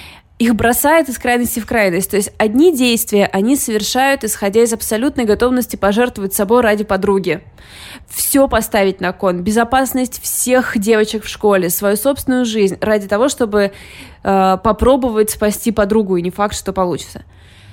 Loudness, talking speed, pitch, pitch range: -15 LUFS, 150 wpm, 220 Hz, 200-245 Hz